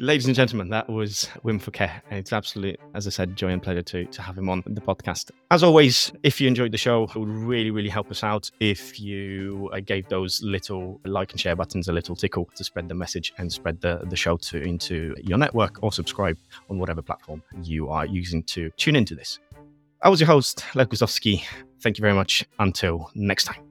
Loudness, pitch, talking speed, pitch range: -24 LUFS, 100 Hz, 220 wpm, 90-110 Hz